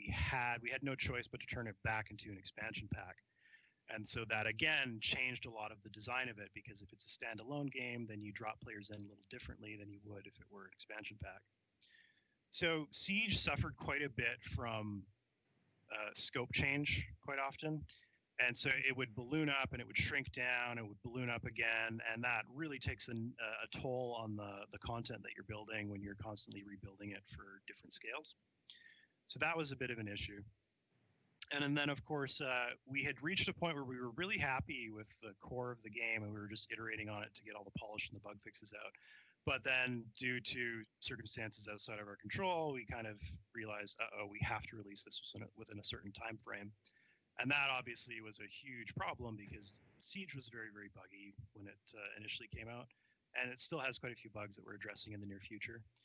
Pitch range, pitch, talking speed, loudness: 105-125 Hz, 115 Hz, 220 wpm, -42 LUFS